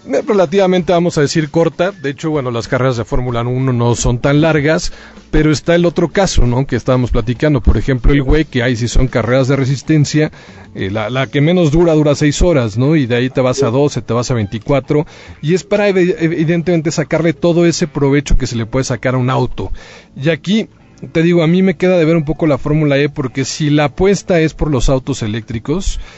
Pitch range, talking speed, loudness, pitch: 125-165 Hz, 225 wpm, -14 LUFS, 145 Hz